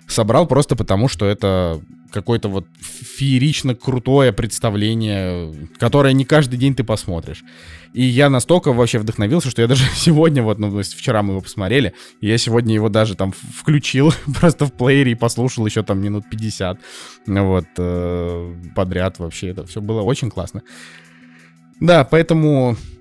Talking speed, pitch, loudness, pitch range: 150 wpm, 110 Hz, -17 LUFS, 95-130 Hz